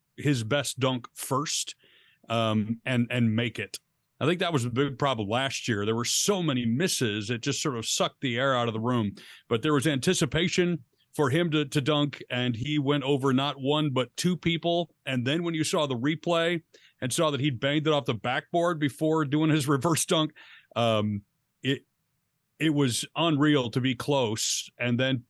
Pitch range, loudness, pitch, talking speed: 125-155 Hz, -27 LUFS, 140 Hz, 195 wpm